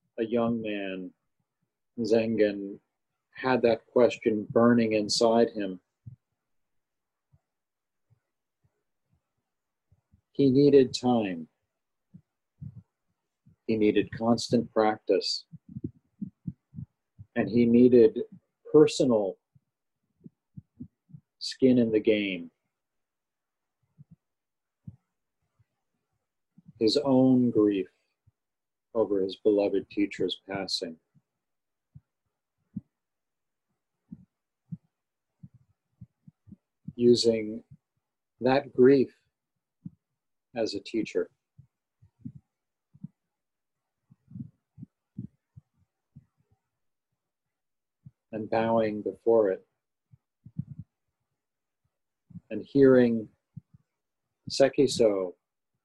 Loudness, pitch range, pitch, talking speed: -25 LUFS, 105-130 Hz, 115 Hz, 50 wpm